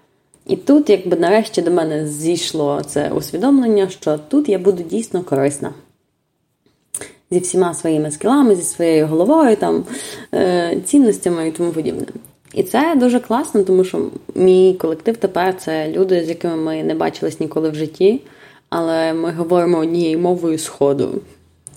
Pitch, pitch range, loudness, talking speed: 175 Hz, 160-200 Hz, -16 LUFS, 145 wpm